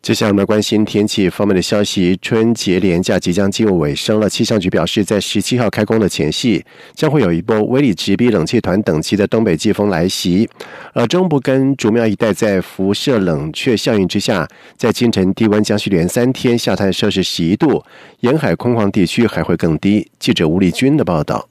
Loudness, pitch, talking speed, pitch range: -15 LUFS, 105 Hz, 310 characters per minute, 95-115 Hz